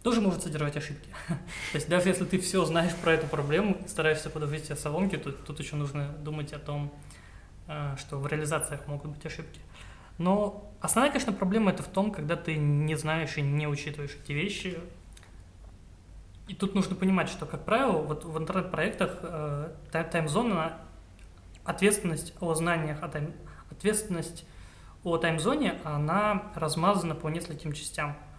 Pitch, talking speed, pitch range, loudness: 160 Hz, 145 wpm, 145-180 Hz, -30 LUFS